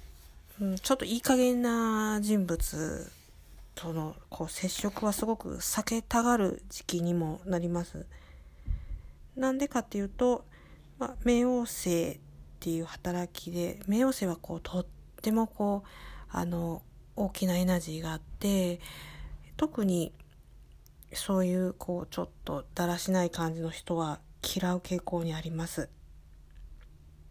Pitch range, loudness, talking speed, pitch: 160-205 Hz, -32 LUFS, 250 characters per minute, 175 Hz